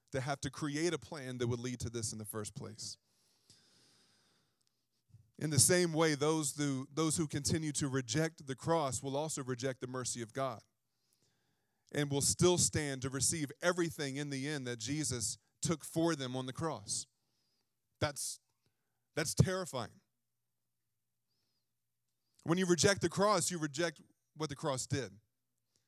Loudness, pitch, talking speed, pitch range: -35 LUFS, 140 Hz, 155 wpm, 120-160 Hz